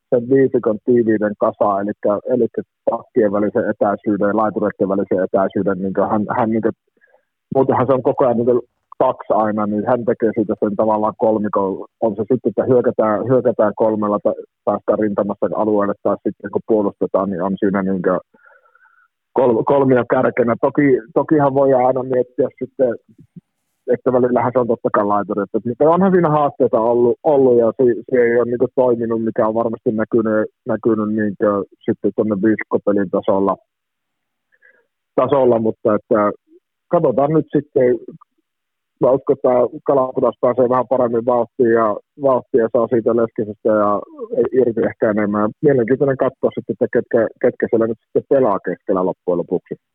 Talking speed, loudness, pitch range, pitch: 155 wpm, -17 LUFS, 105-130 Hz, 115 Hz